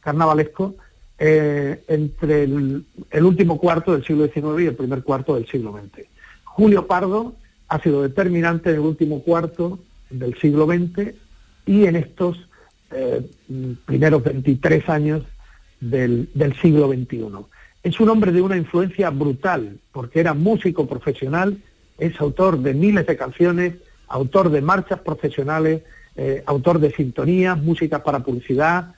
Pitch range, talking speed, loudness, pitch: 140-180 Hz, 140 wpm, -19 LUFS, 155 Hz